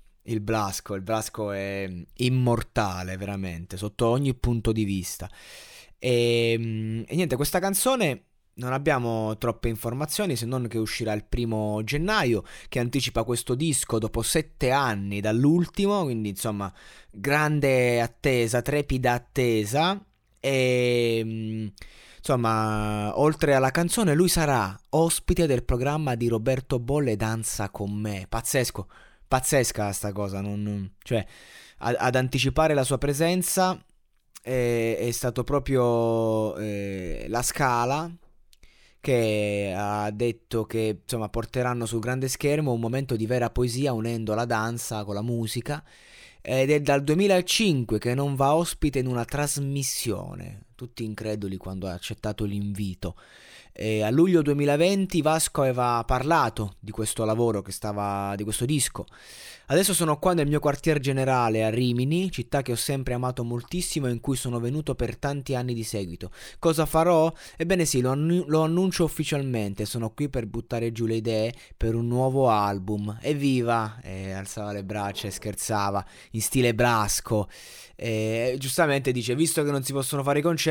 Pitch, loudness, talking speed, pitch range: 120 Hz, -26 LUFS, 145 wpm, 110-140 Hz